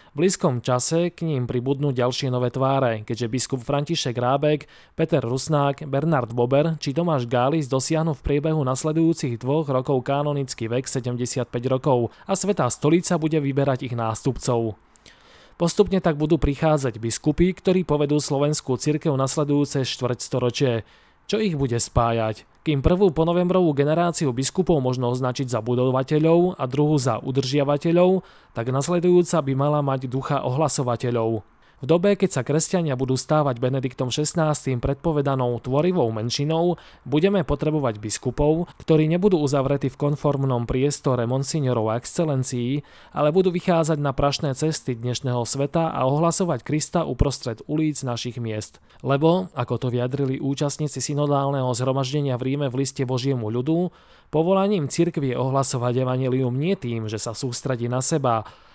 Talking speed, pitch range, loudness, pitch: 140 wpm, 125-160 Hz, -22 LUFS, 140 Hz